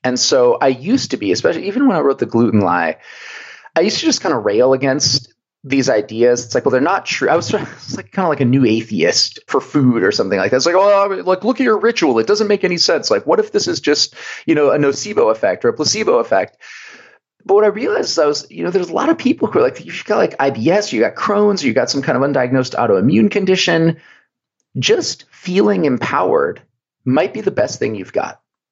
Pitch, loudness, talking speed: 195 Hz, -15 LUFS, 240 wpm